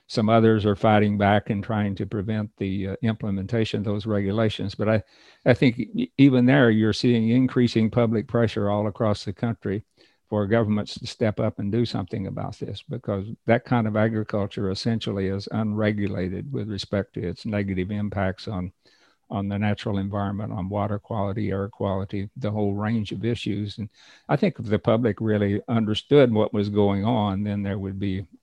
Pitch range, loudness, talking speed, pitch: 100-115 Hz, -24 LUFS, 180 wpm, 105 Hz